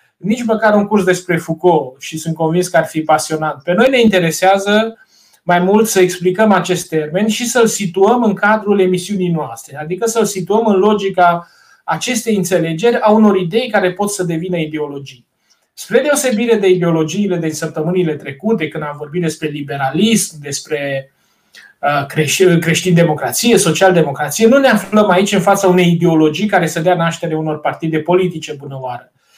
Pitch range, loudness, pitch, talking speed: 155-205 Hz, -14 LUFS, 180 Hz, 155 wpm